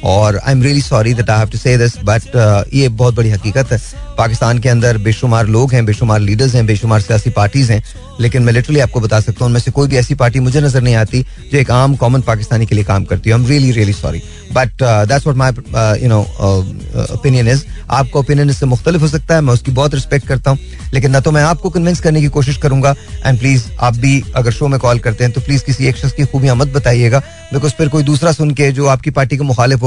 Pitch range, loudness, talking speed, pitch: 115-140 Hz, -12 LUFS, 235 wpm, 125 Hz